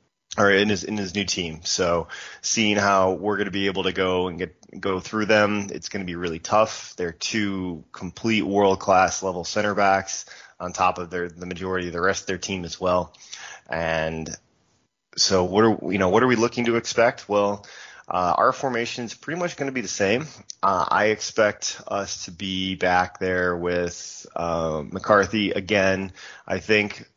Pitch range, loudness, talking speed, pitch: 90-105 Hz, -23 LUFS, 195 wpm, 95 Hz